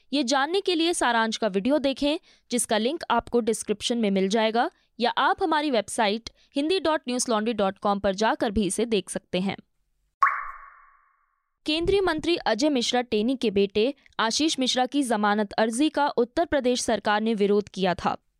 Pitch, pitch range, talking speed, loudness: 245 Hz, 215-305 Hz, 155 wpm, -25 LUFS